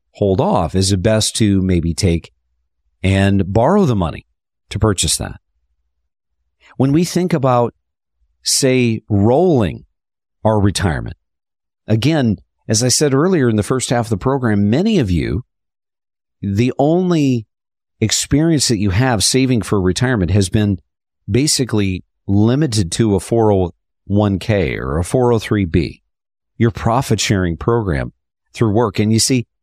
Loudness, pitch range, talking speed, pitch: -16 LUFS, 90-120 Hz, 135 wpm, 105 Hz